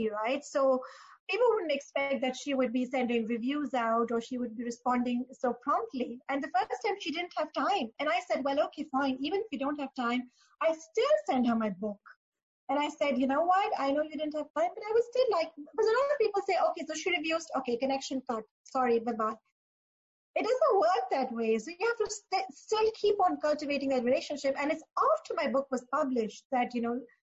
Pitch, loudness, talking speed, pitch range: 280 Hz, -31 LUFS, 225 wpm, 250-330 Hz